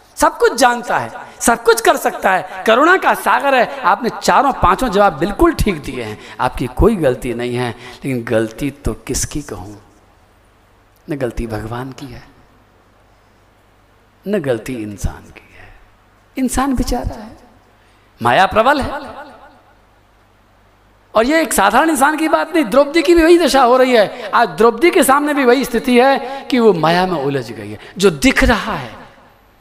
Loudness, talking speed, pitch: -14 LUFS, 165 wpm, 140 Hz